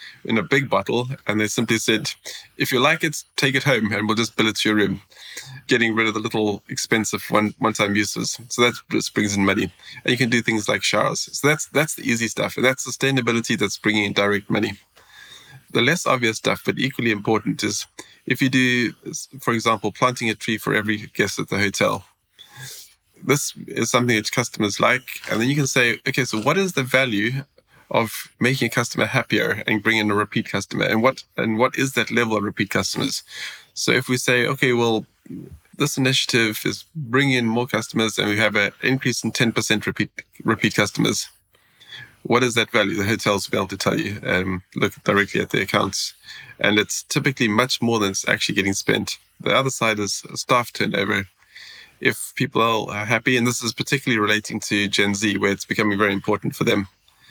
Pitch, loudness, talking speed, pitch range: 115 Hz, -21 LUFS, 205 wpm, 105-125 Hz